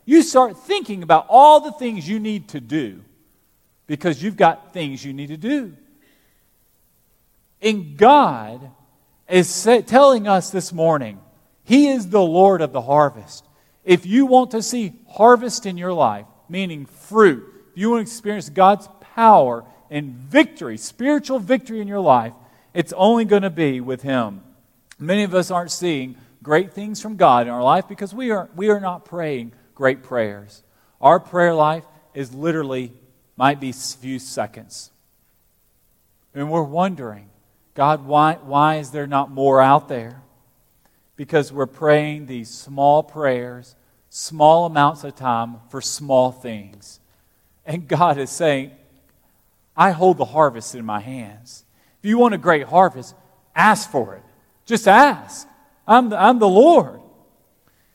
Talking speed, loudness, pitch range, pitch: 155 wpm, -17 LUFS, 130-195 Hz, 155 Hz